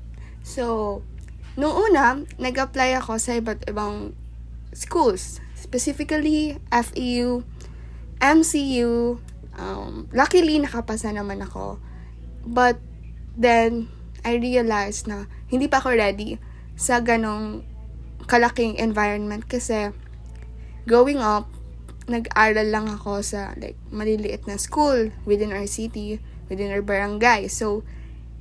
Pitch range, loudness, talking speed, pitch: 200-245 Hz, -22 LUFS, 100 wpm, 220 Hz